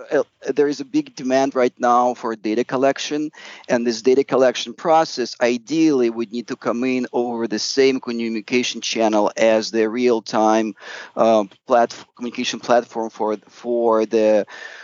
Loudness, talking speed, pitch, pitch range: -19 LUFS, 150 wpm, 120 Hz, 115-130 Hz